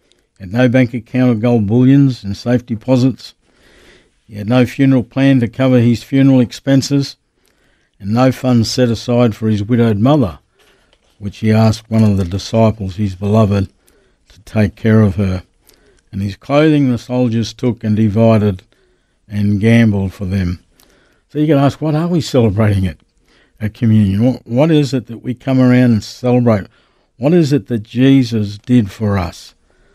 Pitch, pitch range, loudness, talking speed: 115 Hz, 105-125 Hz, -14 LUFS, 165 wpm